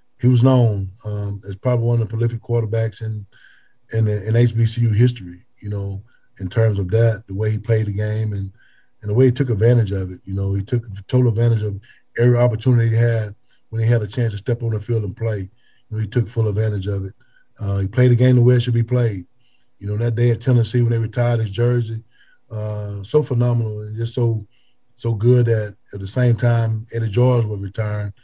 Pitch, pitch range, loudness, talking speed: 115 Hz, 105-120 Hz, -19 LUFS, 230 wpm